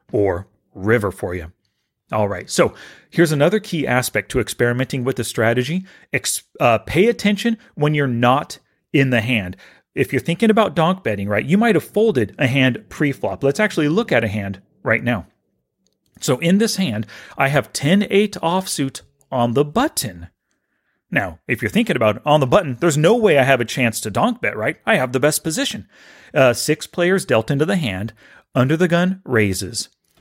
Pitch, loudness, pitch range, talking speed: 140 Hz, -18 LUFS, 120-175 Hz, 185 wpm